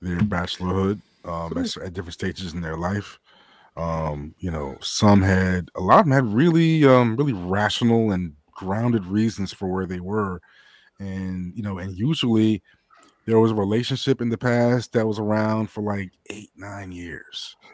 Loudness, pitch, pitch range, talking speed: -22 LUFS, 100 Hz, 90-115 Hz, 175 wpm